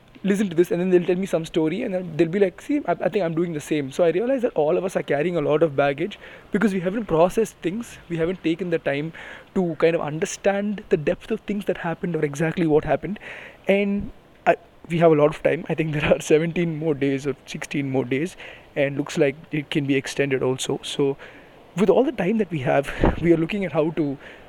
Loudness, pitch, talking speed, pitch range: -23 LUFS, 165 Hz, 245 wpm, 150-190 Hz